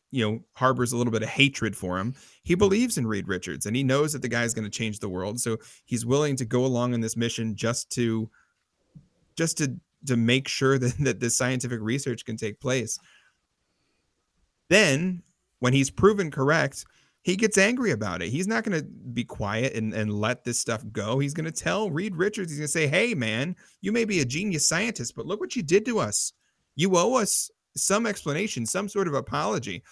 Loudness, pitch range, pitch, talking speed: -26 LUFS, 115-175 Hz, 130 Hz, 215 wpm